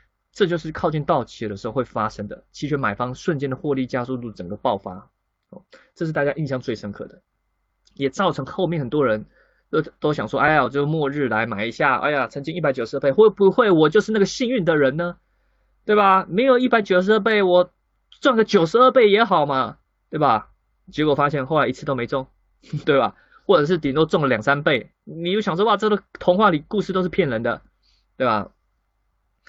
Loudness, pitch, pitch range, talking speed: -20 LUFS, 155 Hz, 135-190 Hz, 305 characters per minute